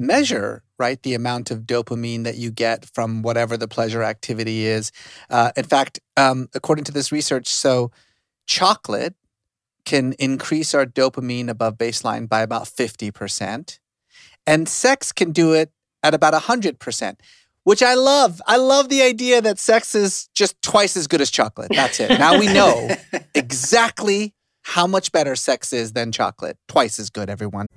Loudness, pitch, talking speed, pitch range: -19 LUFS, 130 Hz, 160 wpm, 115-175 Hz